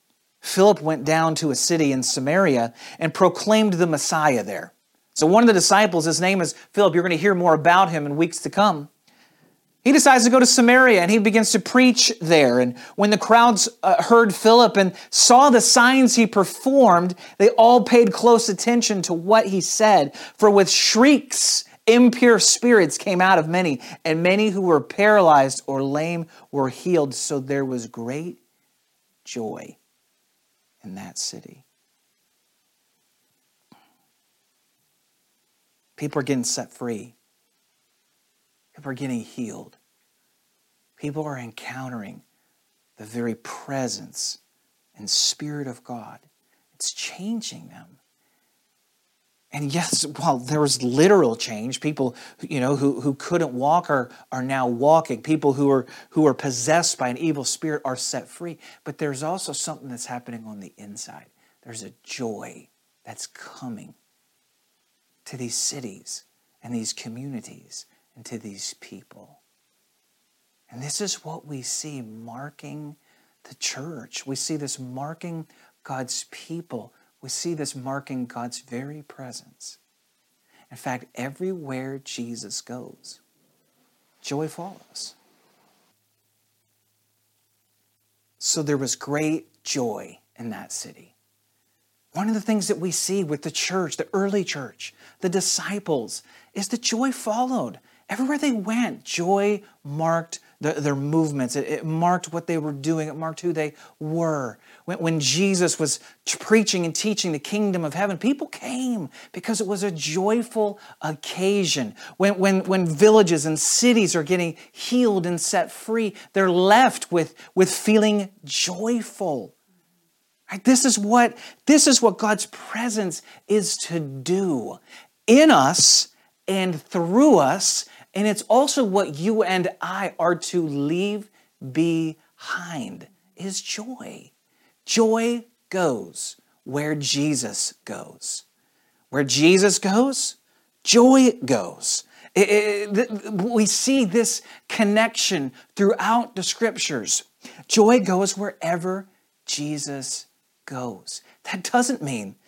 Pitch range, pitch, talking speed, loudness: 140-210 Hz, 175 Hz, 135 wpm, -20 LUFS